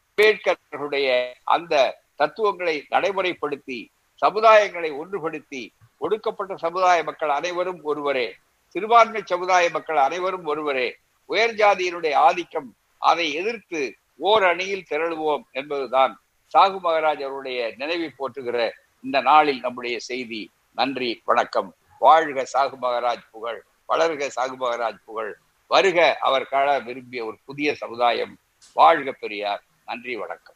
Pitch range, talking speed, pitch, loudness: 130-190 Hz, 105 wpm, 155 Hz, -22 LUFS